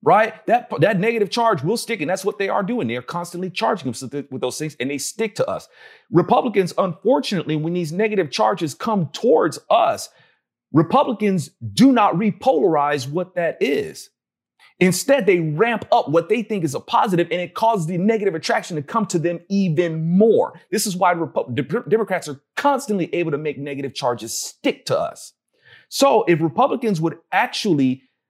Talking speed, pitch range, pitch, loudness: 180 wpm, 160-220 Hz, 180 Hz, -20 LUFS